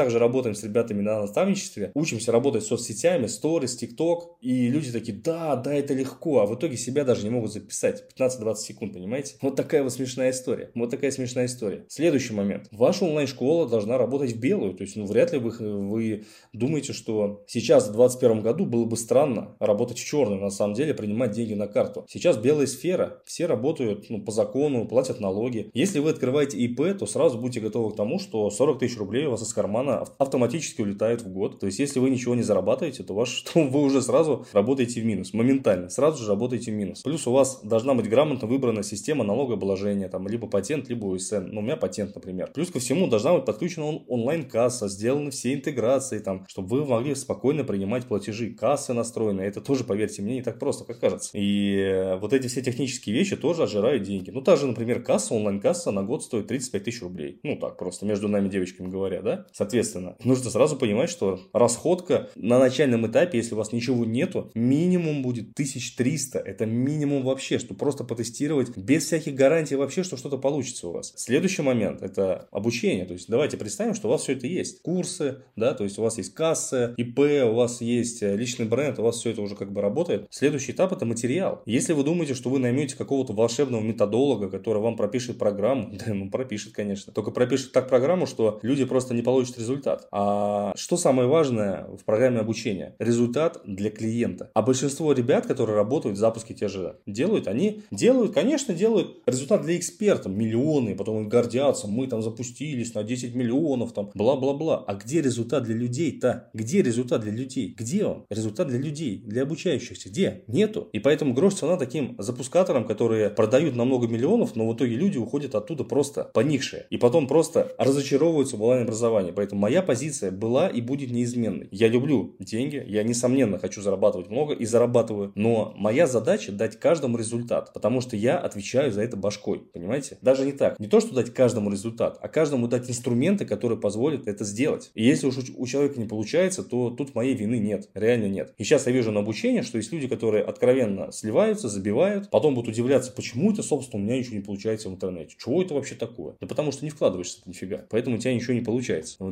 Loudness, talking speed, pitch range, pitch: -25 LUFS, 195 wpm, 110-140 Hz, 120 Hz